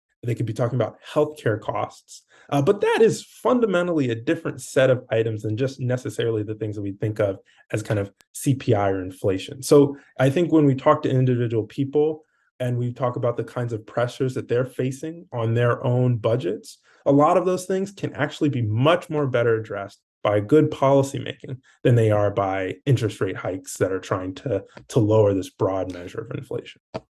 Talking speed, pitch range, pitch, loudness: 200 wpm, 110-145 Hz, 125 Hz, -23 LUFS